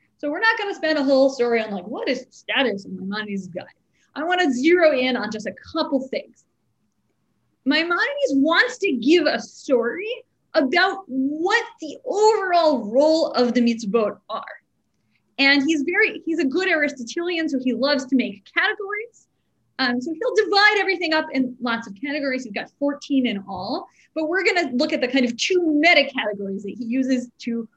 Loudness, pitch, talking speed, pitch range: -21 LUFS, 285 Hz, 185 wpm, 245-340 Hz